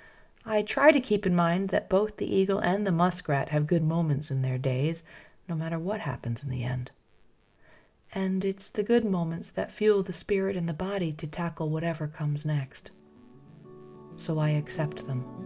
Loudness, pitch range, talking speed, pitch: -28 LUFS, 145-195 Hz, 185 wpm, 165 Hz